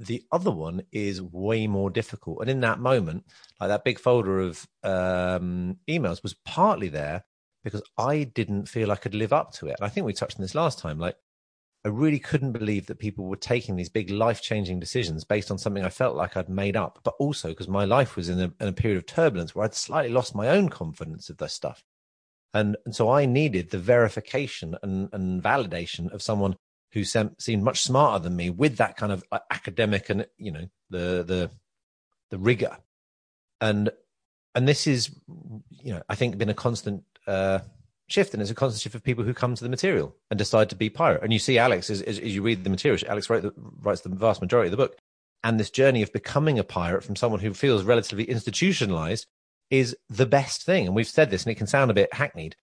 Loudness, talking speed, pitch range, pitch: -26 LUFS, 220 wpm, 95-125 Hz, 105 Hz